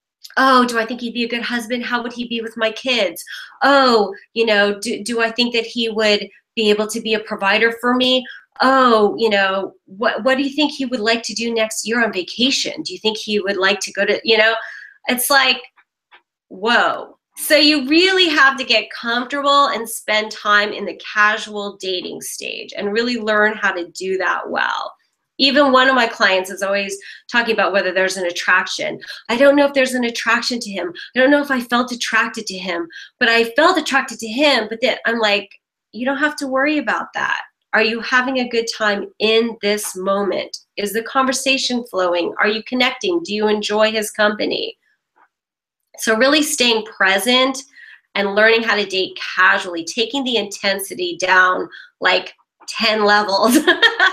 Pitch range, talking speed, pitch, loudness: 205-260 Hz, 195 wpm, 230 Hz, -17 LUFS